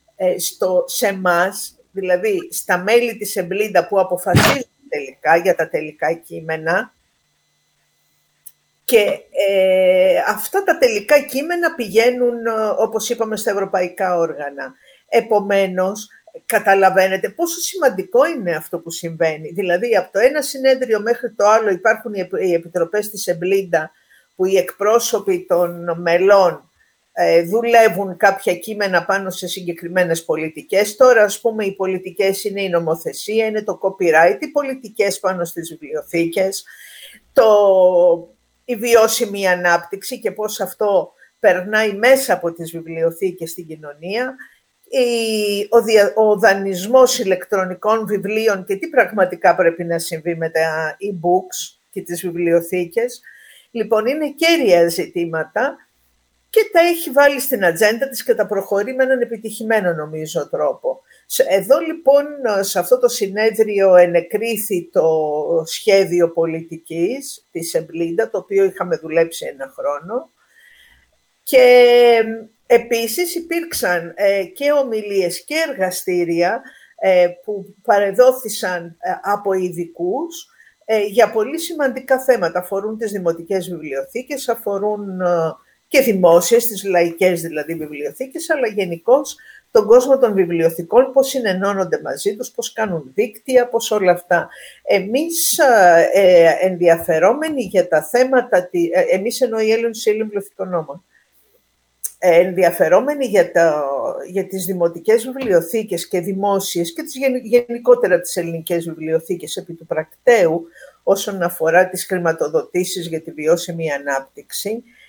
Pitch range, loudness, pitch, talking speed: 175-240 Hz, -17 LUFS, 195 Hz, 125 wpm